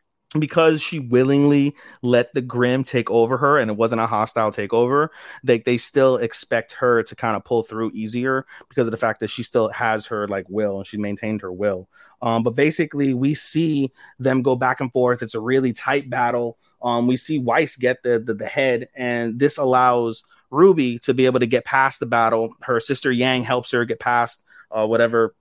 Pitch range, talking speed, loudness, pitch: 115-135 Hz, 205 wpm, -20 LUFS, 125 Hz